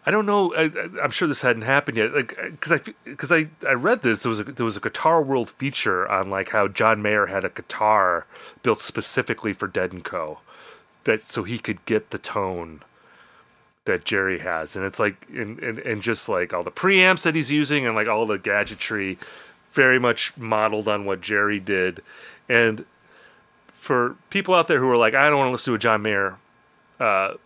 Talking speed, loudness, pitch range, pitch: 205 wpm, -22 LUFS, 105-140 Hz, 115 Hz